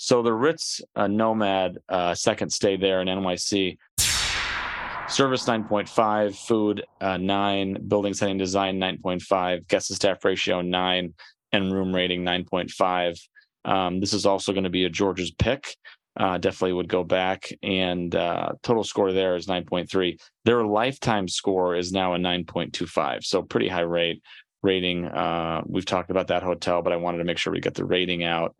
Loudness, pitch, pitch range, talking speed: -24 LUFS, 95 Hz, 90-100 Hz, 170 wpm